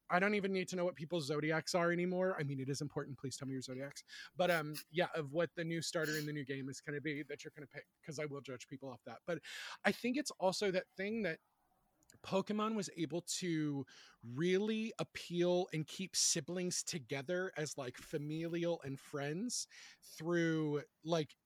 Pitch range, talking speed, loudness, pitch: 145-180 Hz, 205 wpm, -39 LUFS, 165 Hz